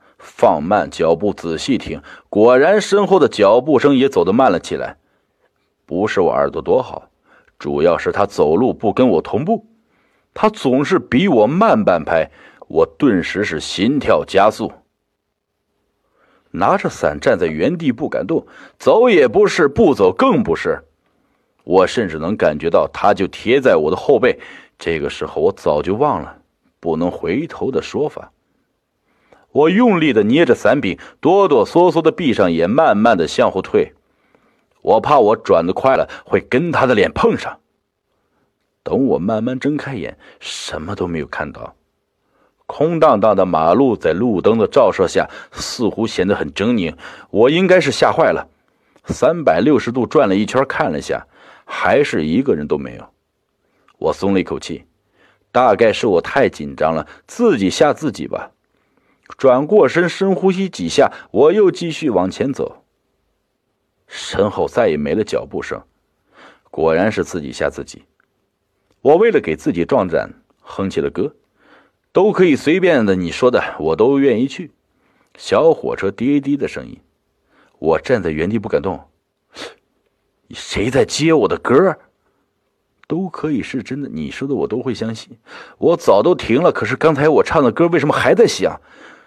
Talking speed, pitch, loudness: 225 characters per minute, 260 Hz, -16 LUFS